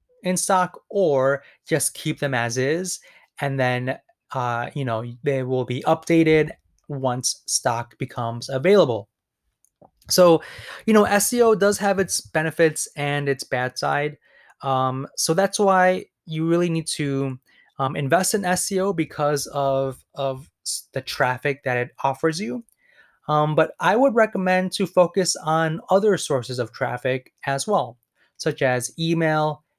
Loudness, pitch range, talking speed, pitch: -22 LUFS, 130-180 Hz, 145 wpm, 150 Hz